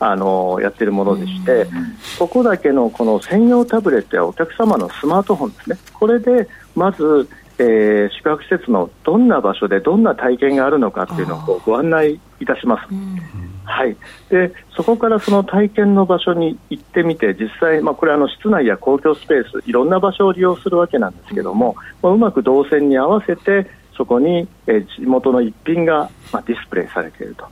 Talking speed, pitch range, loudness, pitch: 380 characters per minute, 135-210 Hz, -16 LUFS, 175 Hz